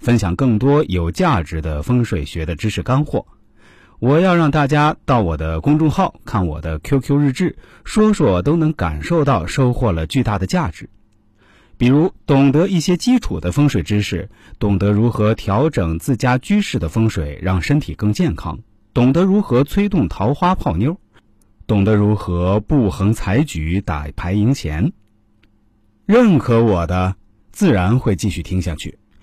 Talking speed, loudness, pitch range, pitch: 235 characters per minute, -17 LUFS, 95-145 Hz, 105 Hz